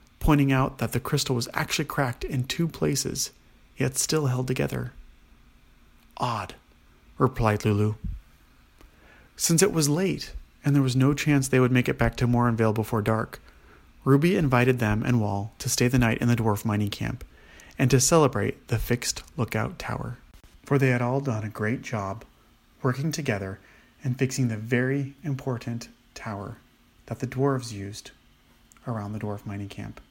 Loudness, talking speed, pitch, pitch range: -25 LUFS, 165 wpm, 120 Hz, 105-135 Hz